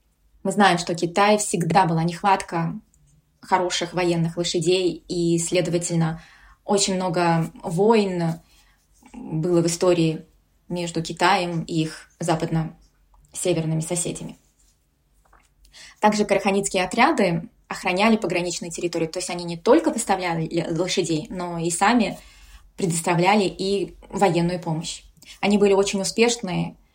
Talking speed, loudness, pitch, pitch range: 105 wpm, -22 LUFS, 175 Hz, 170-195 Hz